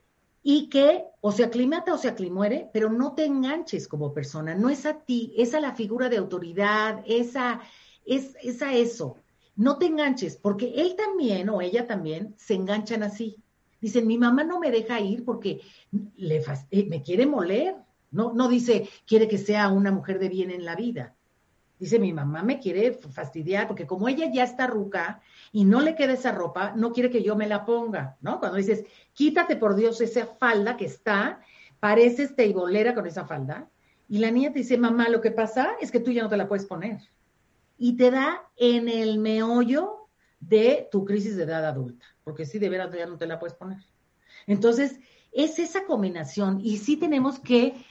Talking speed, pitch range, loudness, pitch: 195 wpm, 200-255 Hz, -25 LUFS, 225 Hz